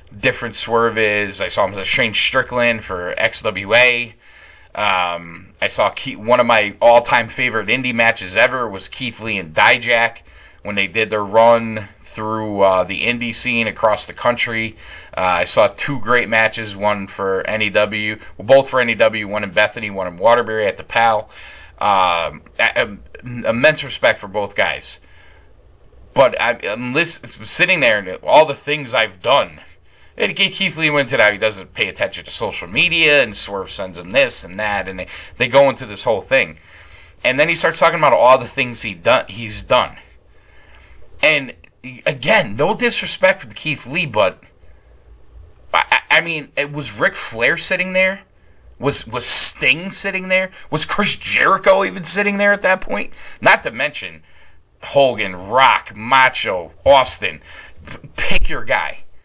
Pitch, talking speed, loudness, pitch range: 115 Hz, 170 wpm, -16 LUFS, 105-140 Hz